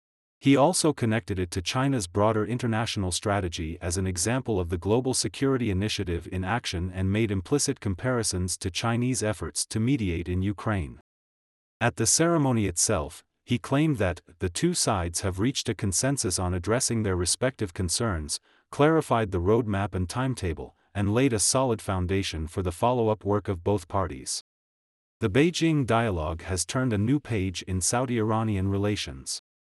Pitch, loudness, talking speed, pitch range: 105 Hz, -26 LUFS, 160 wpm, 90-120 Hz